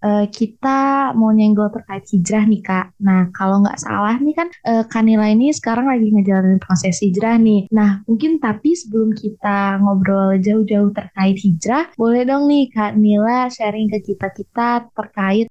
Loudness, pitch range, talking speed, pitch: -16 LUFS, 200-230 Hz, 165 wpm, 215 Hz